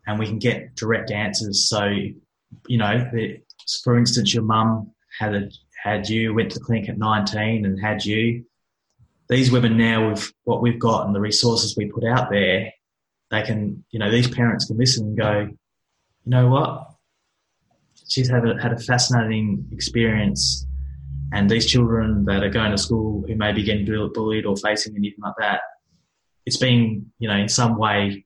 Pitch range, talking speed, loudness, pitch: 105-115 Hz, 180 wpm, -21 LUFS, 110 Hz